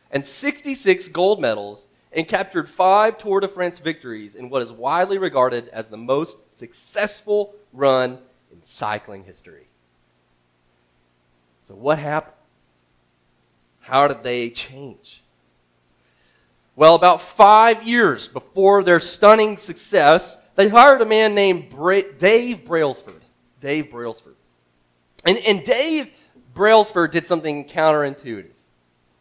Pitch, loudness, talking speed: 140 Hz, -17 LUFS, 115 wpm